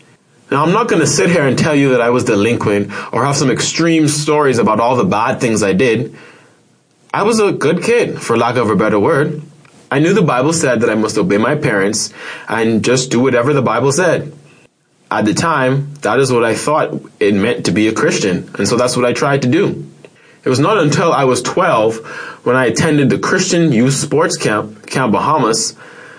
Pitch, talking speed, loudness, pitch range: 140 Hz, 215 wpm, -13 LUFS, 120-155 Hz